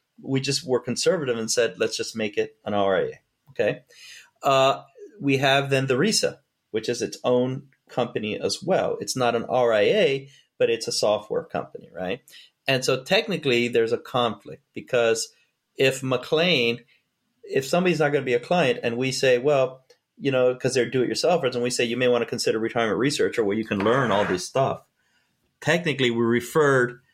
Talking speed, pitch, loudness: 190 wpm, 135 Hz, -23 LUFS